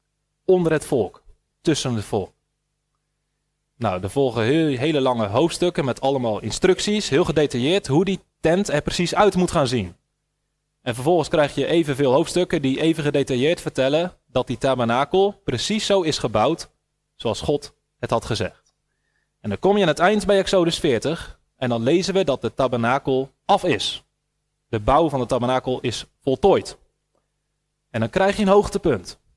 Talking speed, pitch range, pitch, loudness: 165 wpm, 130-175 Hz, 145 Hz, -21 LUFS